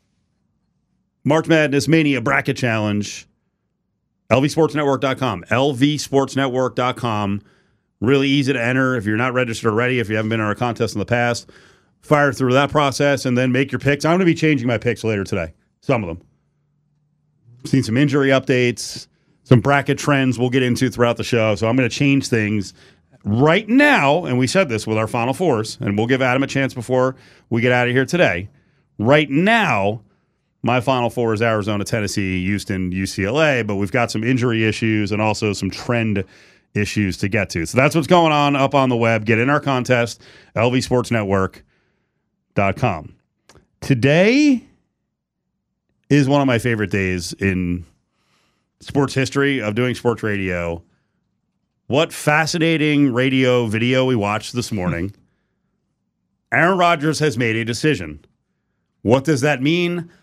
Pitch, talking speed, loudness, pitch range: 125 Hz, 160 wpm, -18 LUFS, 110-140 Hz